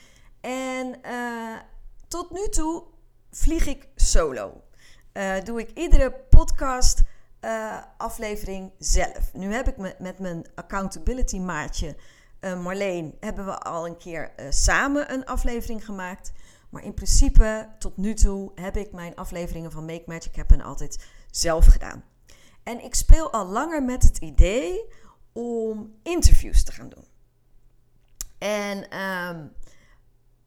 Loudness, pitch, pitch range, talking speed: -26 LUFS, 210 Hz, 180-250 Hz, 130 wpm